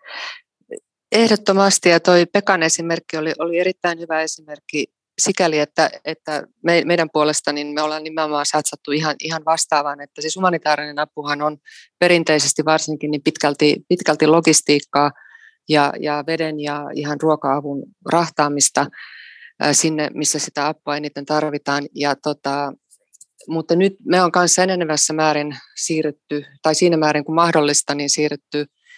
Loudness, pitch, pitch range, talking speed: -18 LUFS, 155 Hz, 150-170 Hz, 130 wpm